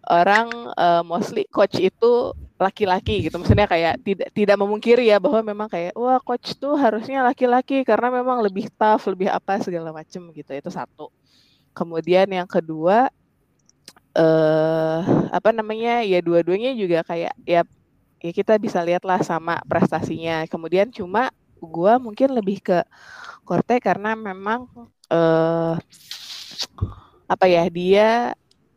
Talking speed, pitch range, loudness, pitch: 135 wpm, 170-230 Hz, -20 LUFS, 195 Hz